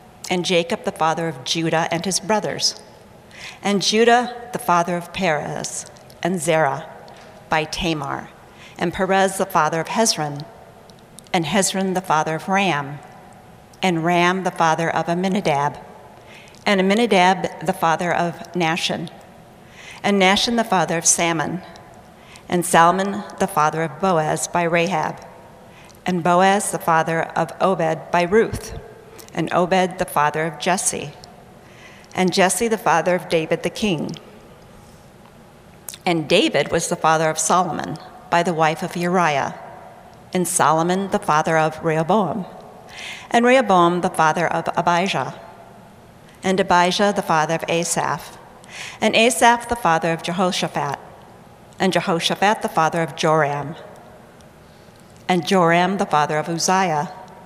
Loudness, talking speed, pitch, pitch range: -19 LUFS, 135 wpm, 175 Hz, 160-190 Hz